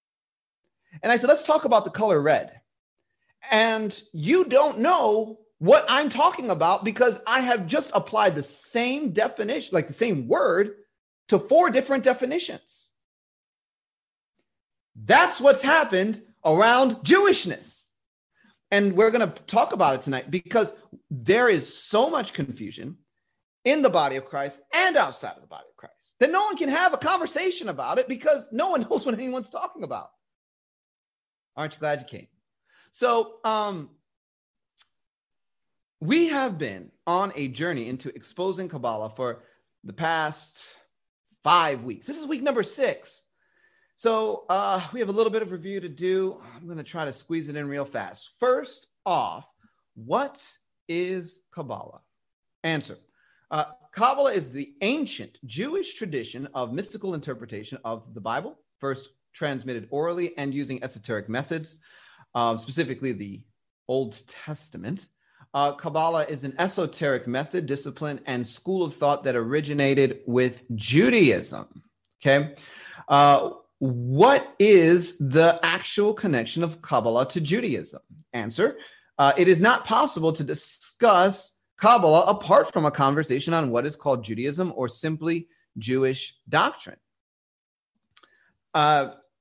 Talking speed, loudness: 140 wpm, -23 LUFS